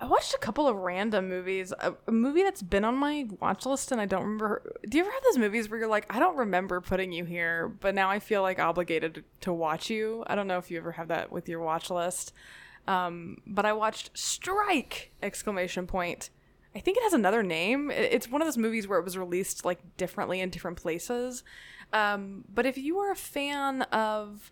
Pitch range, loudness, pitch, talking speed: 180-245 Hz, -30 LUFS, 205 Hz, 220 wpm